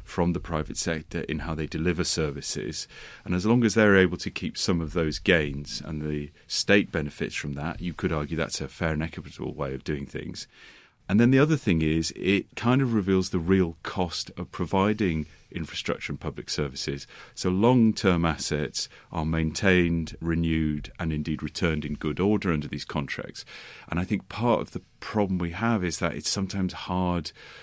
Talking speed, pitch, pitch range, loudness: 190 wpm, 85 Hz, 75-95 Hz, -27 LUFS